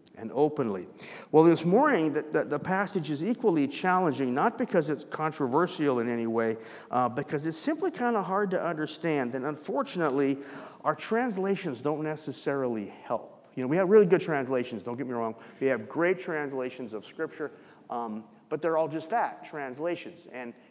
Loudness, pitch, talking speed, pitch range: -29 LUFS, 155 Hz, 170 wpm, 130-180 Hz